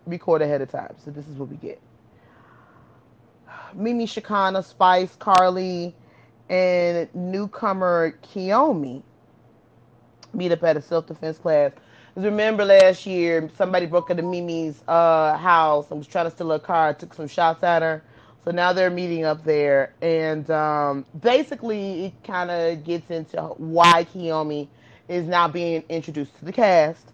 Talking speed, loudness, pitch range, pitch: 155 wpm, -21 LUFS, 155-180 Hz, 170 Hz